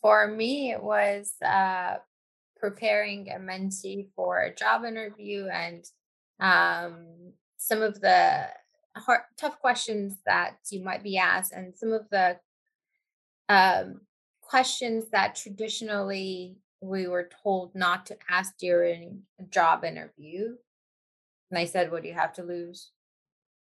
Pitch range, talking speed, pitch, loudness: 180-225 Hz, 135 wpm, 195 Hz, -27 LUFS